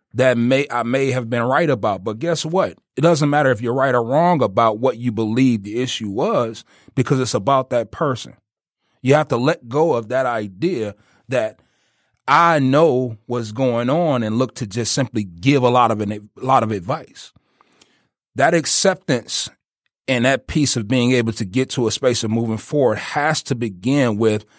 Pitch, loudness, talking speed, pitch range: 125 Hz, -18 LUFS, 195 wpm, 115-140 Hz